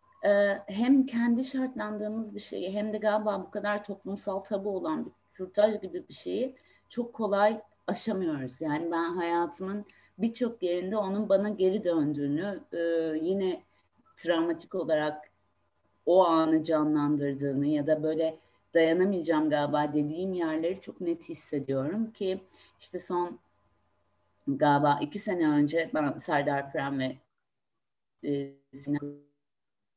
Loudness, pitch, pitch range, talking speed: -29 LUFS, 170 Hz, 150-205 Hz, 115 wpm